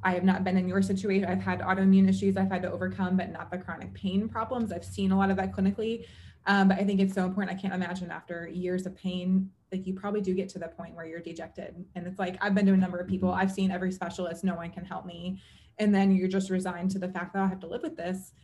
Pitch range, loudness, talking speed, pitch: 180-195 Hz, -29 LUFS, 285 wpm, 185 Hz